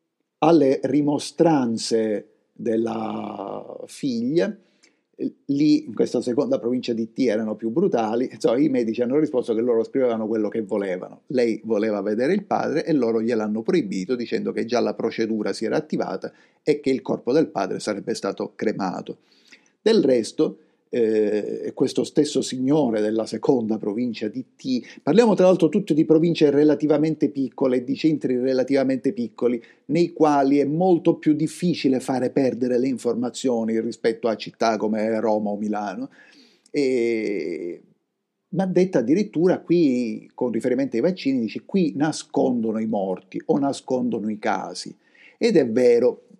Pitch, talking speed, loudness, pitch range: 130 Hz, 145 wpm, -22 LUFS, 115-160 Hz